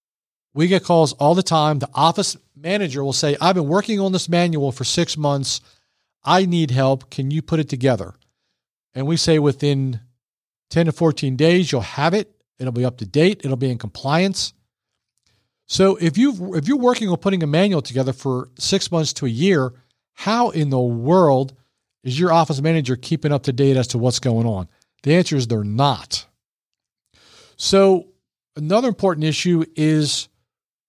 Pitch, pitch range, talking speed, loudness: 155 Hz, 130-175 Hz, 180 wpm, -19 LUFS